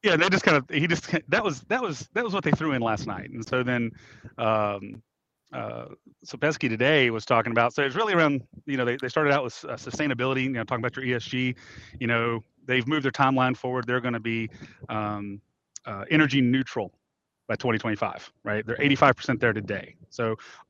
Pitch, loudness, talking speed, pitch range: 125 Hz, -25 LUFS, 210 wpm, 115-140 Hz